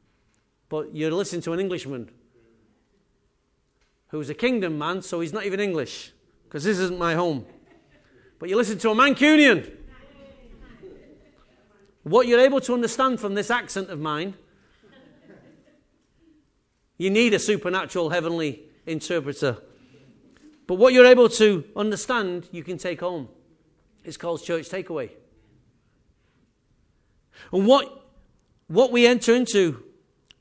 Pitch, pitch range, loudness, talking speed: 190 Hz, 165-240 Hz, -22 LUFS, 120 wpm